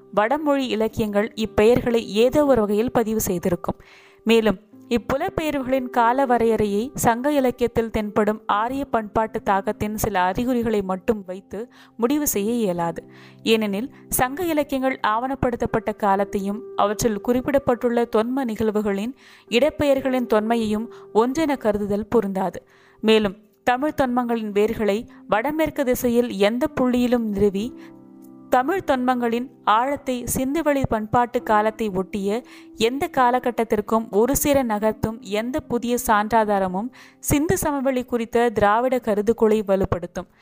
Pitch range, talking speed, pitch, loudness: 210-255 Hz, 105 wpm, 230 Hz, -22 LUFS